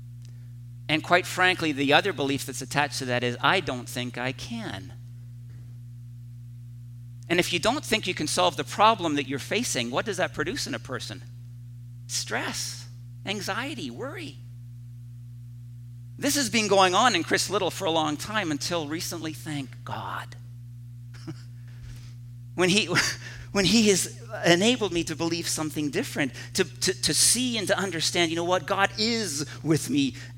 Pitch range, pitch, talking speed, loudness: 120-165 Hz, 125 Hz, 155 wpm, -25 LUFS